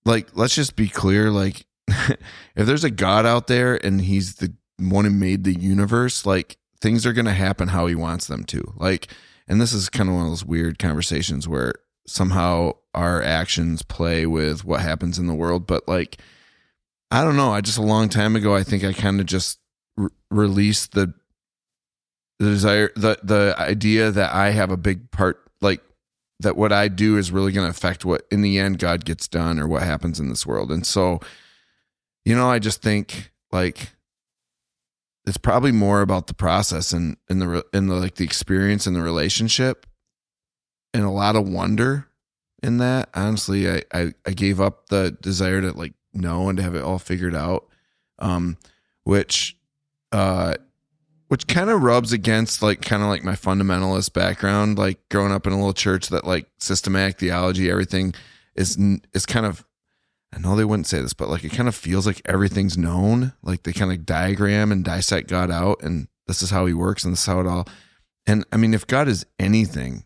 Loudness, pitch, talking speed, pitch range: -21 LUFS, 95 Hz, 195 wpm, 90-105 Hz